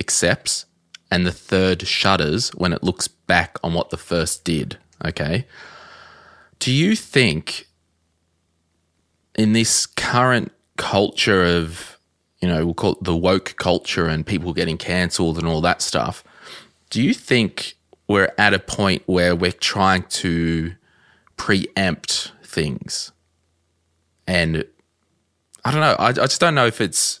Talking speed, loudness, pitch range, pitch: 140 wpm, -19 LUFS, 85-90 Hz, 85 Hz